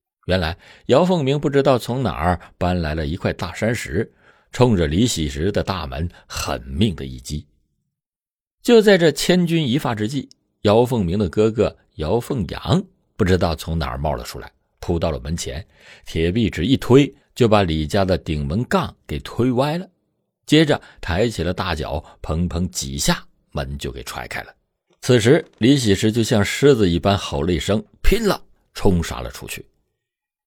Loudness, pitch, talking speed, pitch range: -20 LUFS, 100 Hz, 240 characters per minute, 80-125 Hz